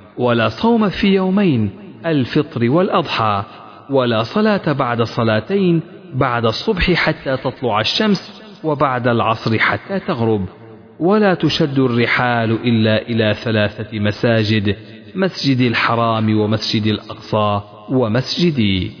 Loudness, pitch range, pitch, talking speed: -17 LUFS, 110-165 Hz, 120 Hz, 100 wpm